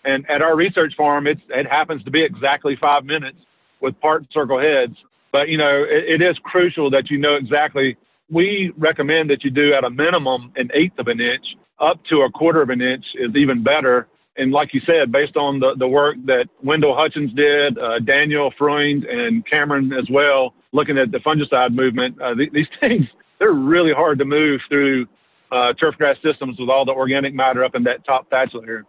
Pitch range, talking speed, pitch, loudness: 130-155 Hz, 210 wpm, 145 Hz, -17 LUFS